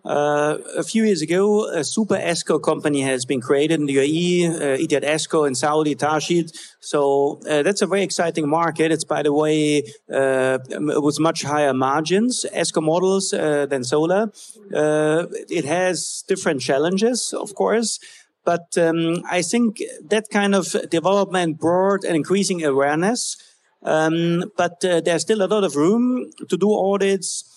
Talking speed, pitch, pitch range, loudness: 160 wpm, 170 Hz, 150-195 Hz, -20 LUFS